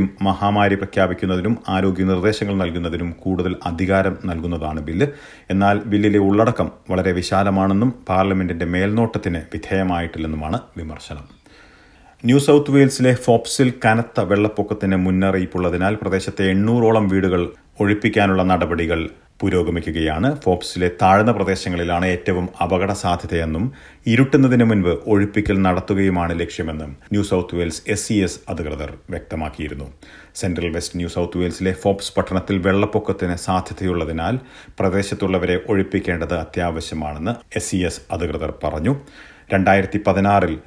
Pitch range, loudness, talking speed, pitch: 85-100 Hz, -19 LUFS, 95 wpm, 95 Hz